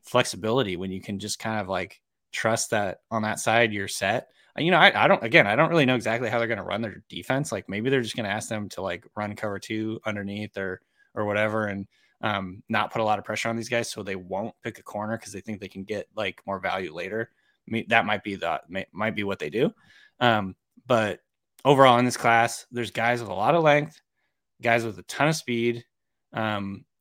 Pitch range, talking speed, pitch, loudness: 100-120 Hz, 240 wpm, 110 Hz, -25 LUFS